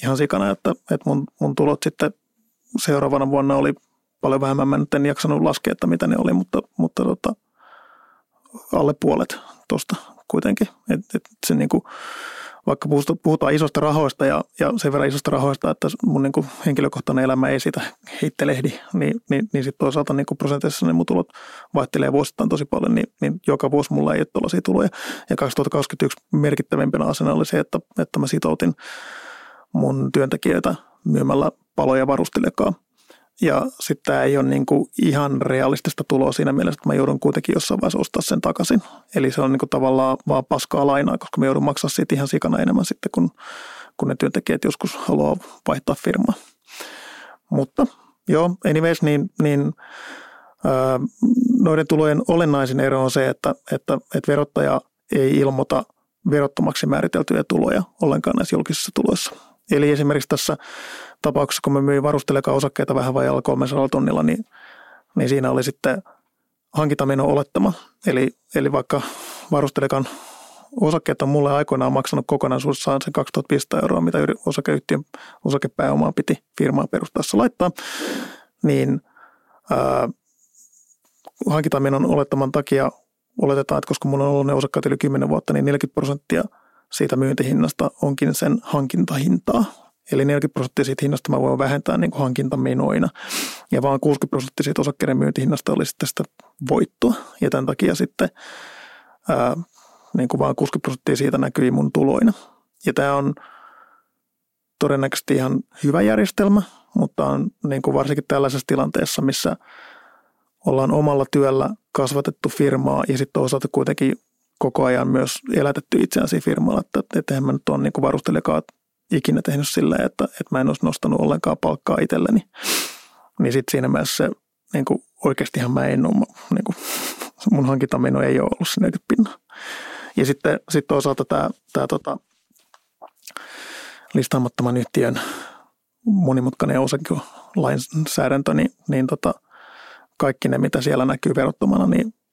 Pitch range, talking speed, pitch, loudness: 135-165 Hz, 145 wpm, 145 Hz, -20 LUFS